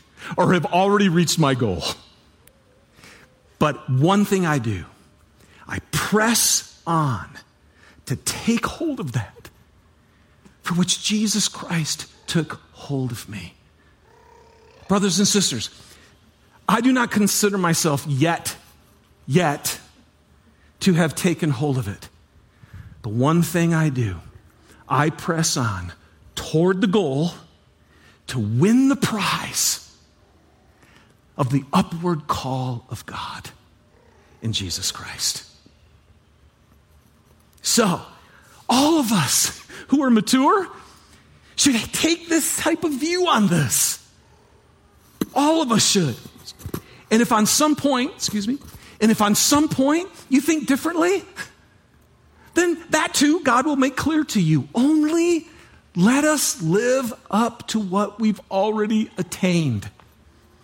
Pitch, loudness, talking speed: 175 Hz, -20 LUFS, 120 wpm